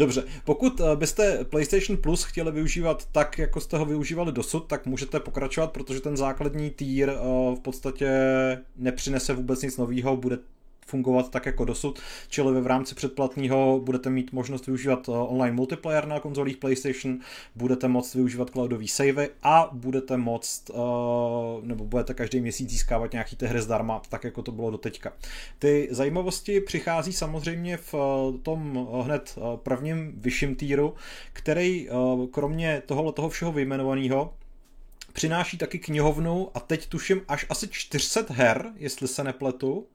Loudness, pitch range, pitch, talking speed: -27 LUFS, 125-155 Hz, 135 Hz, 145 wpm